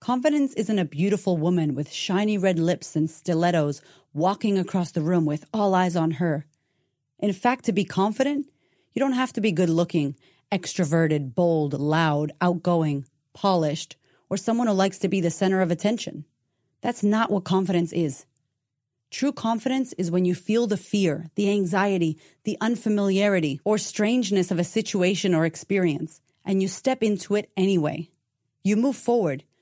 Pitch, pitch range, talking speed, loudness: 180 Hz, 160-205 Hz, 160 wpm, -24 LUFS